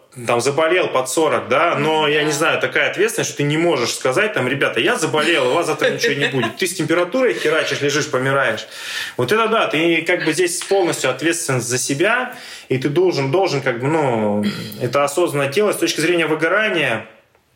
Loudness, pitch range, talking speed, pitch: -17 LUFS, 140-190 Hz, 195 wpm, 160 Hz